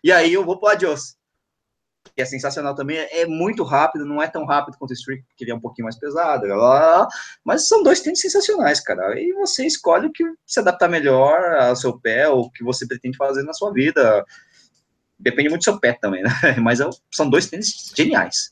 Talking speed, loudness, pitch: 220 wpm, -18 LUFS, 165 Hz